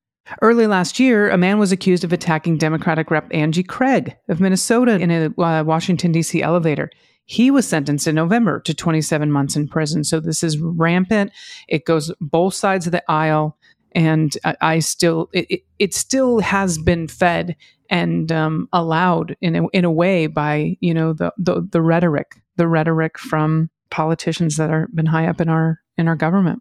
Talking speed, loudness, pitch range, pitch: 185 wpm, -18 LUFS, 160-180 Hz, 165 Hz